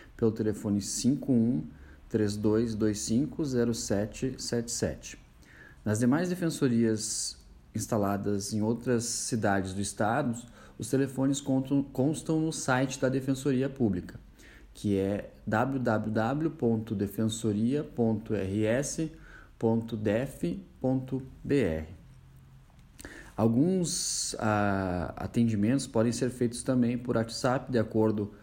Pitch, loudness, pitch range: 115 Hz, -30 LUFS, 105-130 Hz